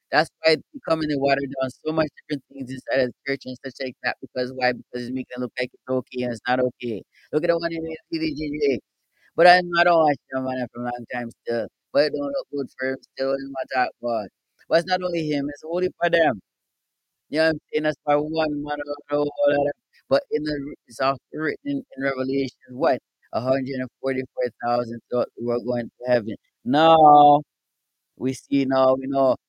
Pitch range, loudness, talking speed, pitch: 125-155 Hz, -23 LUFS, 220 wpm, 135 Hz